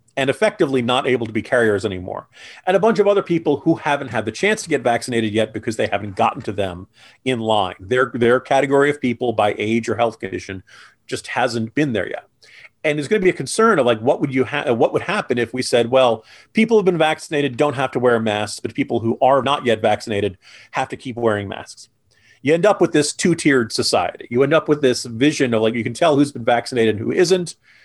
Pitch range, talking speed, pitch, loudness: 115-150 Hz, 235 wpm, 130 Hz, -18 LUFS